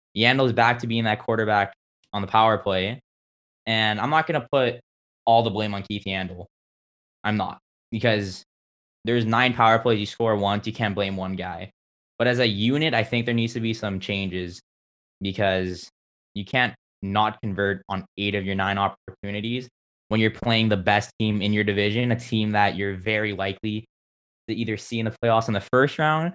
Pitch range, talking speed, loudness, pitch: 95-115 Hz, 195 wpm, -23 LUFS, 105 Hz